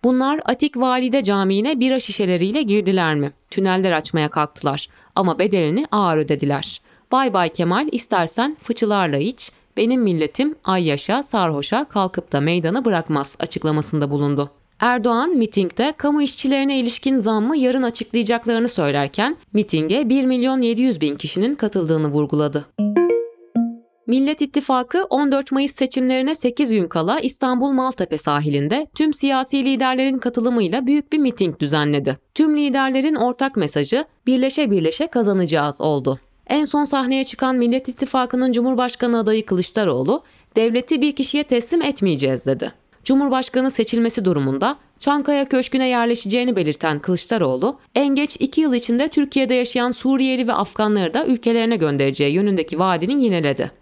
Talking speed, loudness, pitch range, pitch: 130 wpm, -19 LUFS, 175-265 Hz, 235 Hz